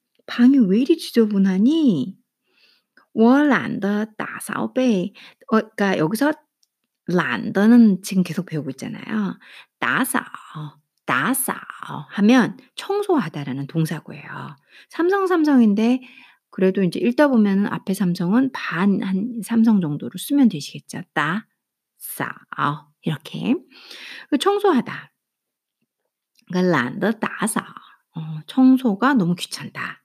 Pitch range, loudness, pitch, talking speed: 185-255 Hz, -20 LUFS, 220 Hz, 230 characters per minute